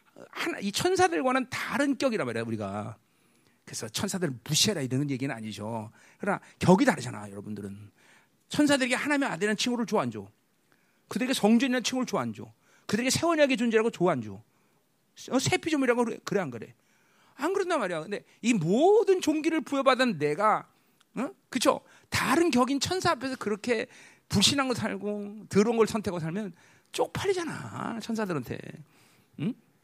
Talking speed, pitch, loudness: 365 characters per minute, 215 Hz, -27 LUFS